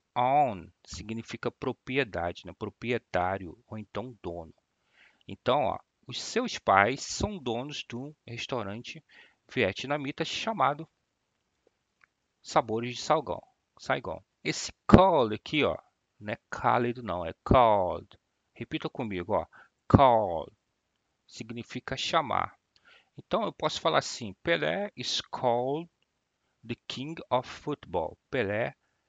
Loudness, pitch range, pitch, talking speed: -29 LUFS, 110-140 Hz, 120 Hz, 105 wpm